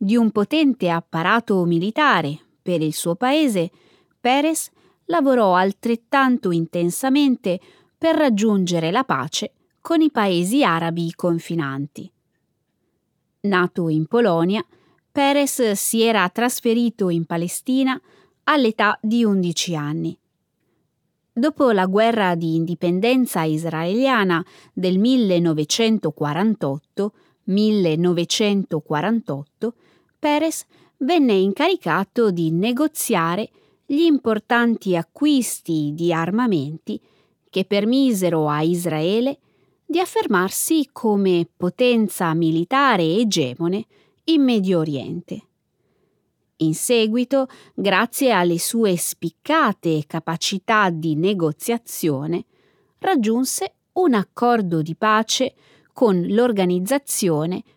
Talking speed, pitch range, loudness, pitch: 85 wpm, 170-245 Hz, -20 LUFS, 200 Hz